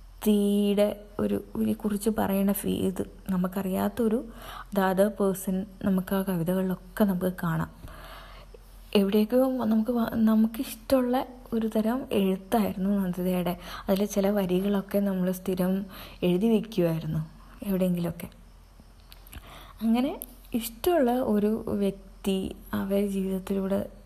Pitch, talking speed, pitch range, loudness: 200 Hz, 90 wpm, 185-220 Hz, -27 LUFS